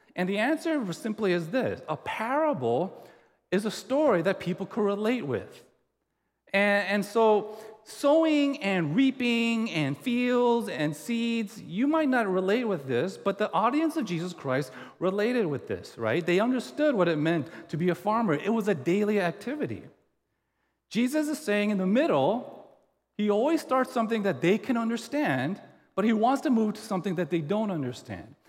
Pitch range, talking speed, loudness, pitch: 185-245 Hz, 170 wpm, -27 LUFS, 215 Hz